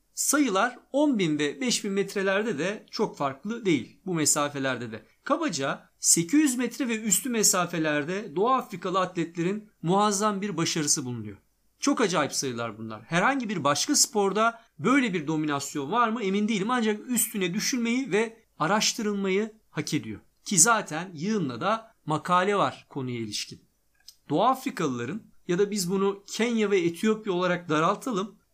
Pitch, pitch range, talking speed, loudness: 195 Hz, 160-220 Hz, 140 wpm, -26 LUFS